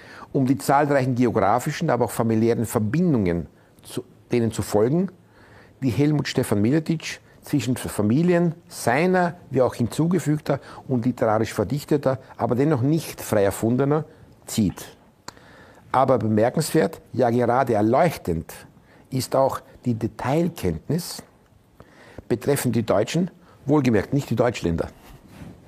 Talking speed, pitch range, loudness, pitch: 110 wpm, 115-150 Hz, -22 LUFS, 125 Hz